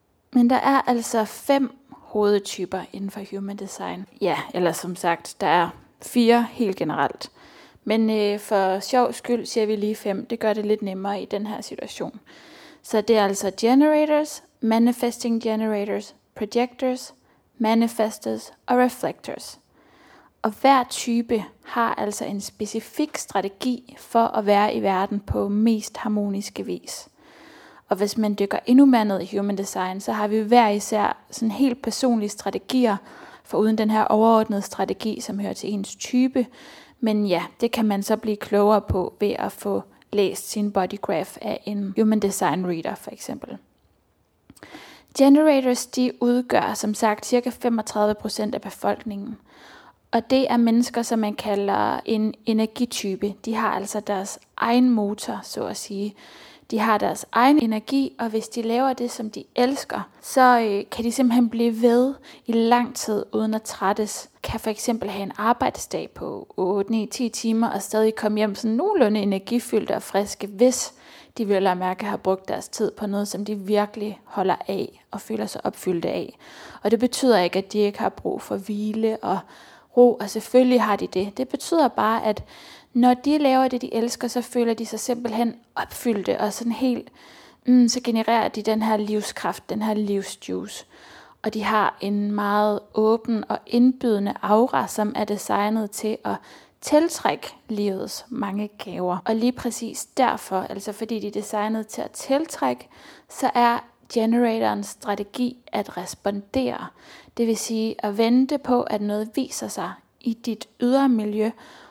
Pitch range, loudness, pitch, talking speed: 205-245 Hz, -23 LUFS, 220 Hz, 165 wpm